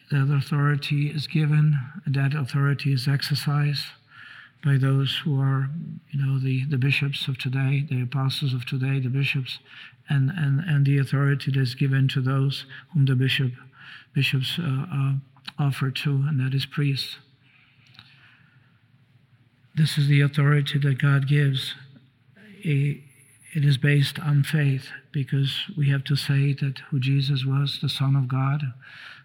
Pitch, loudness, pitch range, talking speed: 140 Hz, -24 LUFS, 135-145 Hz, 150 wpm